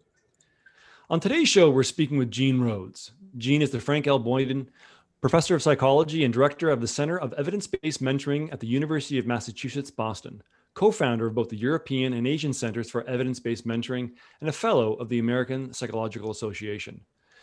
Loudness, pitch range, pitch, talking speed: -26 LUFS, 120-145 Hz, 130 Hz, 185 wpm